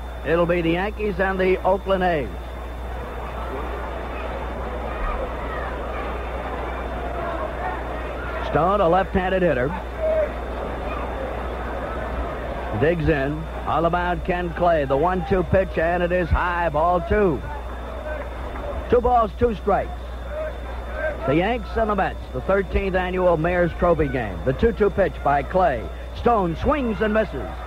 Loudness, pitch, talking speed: -23 LUFS, 170 Hz, 110 wpm